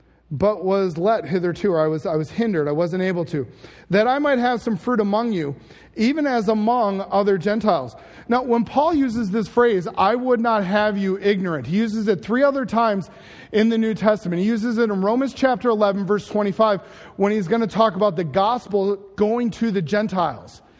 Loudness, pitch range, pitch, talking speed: -20 LUFS, 190-230 Hz, 210 Hz, 200 wpm